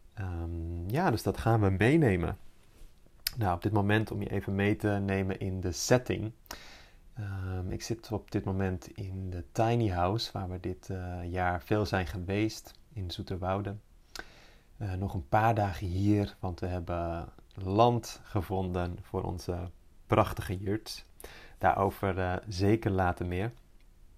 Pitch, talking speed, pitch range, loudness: 95 Hz, 150 wpm, 90-105 Hz, -31 LUFS